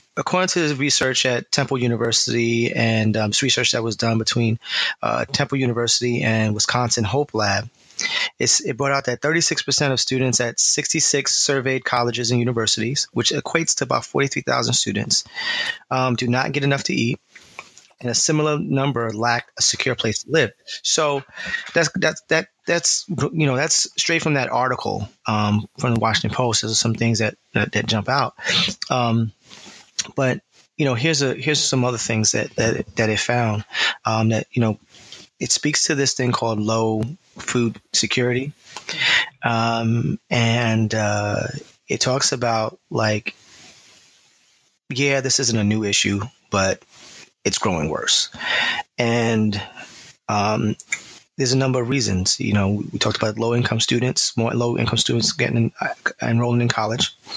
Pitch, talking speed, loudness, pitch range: 120 Hz, 160 wpm, -20 LUFS, 110-135 Hz